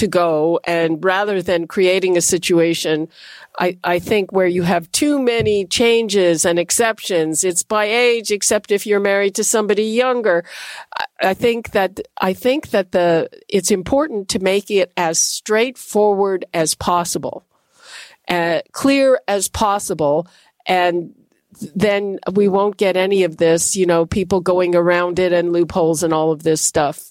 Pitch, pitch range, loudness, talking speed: 190 Hz, 175-210 Hz, -17 LUFS, 155 wpm